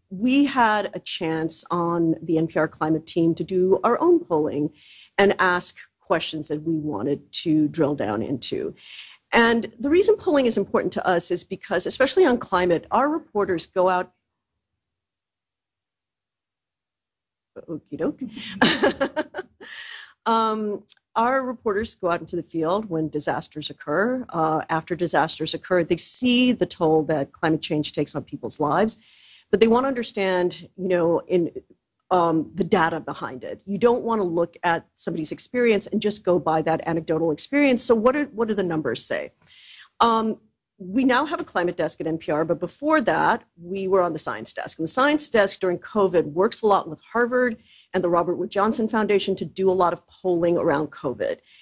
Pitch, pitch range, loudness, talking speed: 185 Hz, 165-225 Hz, -23 LUFS, 170 wpm